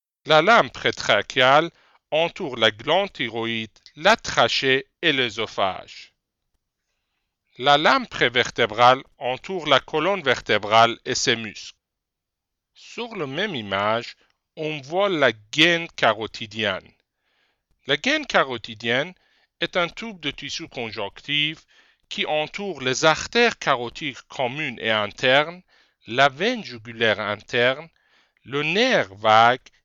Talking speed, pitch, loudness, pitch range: 110 wpm, 145 Hz, -21 LUFS, 120-170 Hz